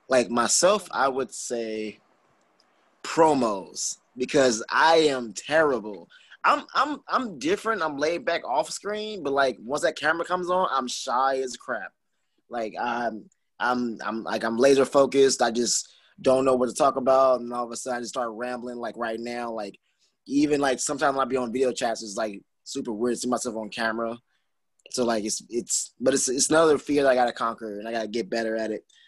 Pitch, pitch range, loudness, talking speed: 125 Hz, 115-135 Hz, -25 LUFS, 200 wpm